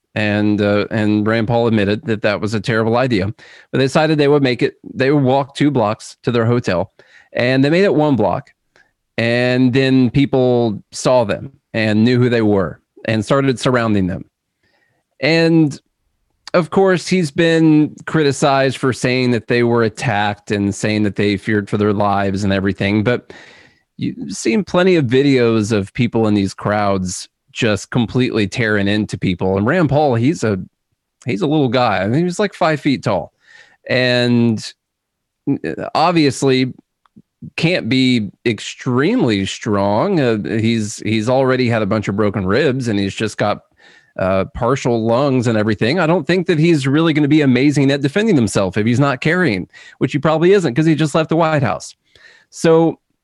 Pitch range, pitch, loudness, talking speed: 105-145 Hz, 120 Hz, -16 LUFS, 175 wpm